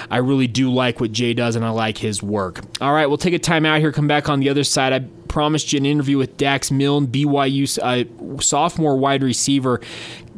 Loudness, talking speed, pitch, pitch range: -18 LUFS, 220 wpm, 140 Hz, 125-145 Hz